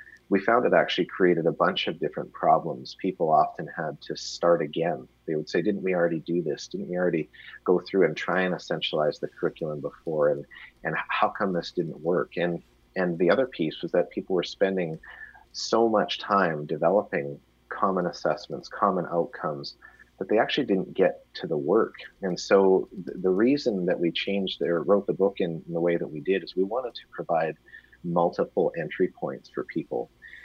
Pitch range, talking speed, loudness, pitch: 85-95 Hz, 195 wpm, -26 LUFS, 85 Hz